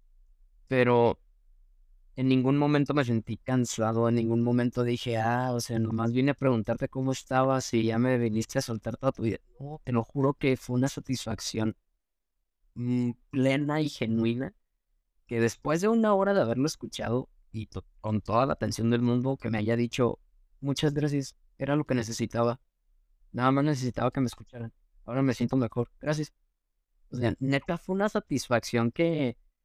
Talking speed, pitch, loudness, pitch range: 170 wpm, 120 Hz, -28 LUFS, 115-135 Hz